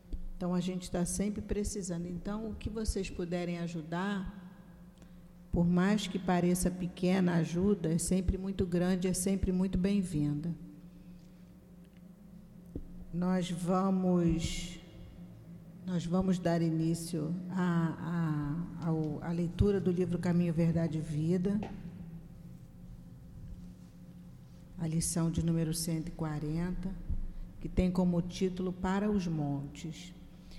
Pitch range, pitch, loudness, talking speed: 165-185 Hz, 175 Hz, -33 LUFS, 110 wpm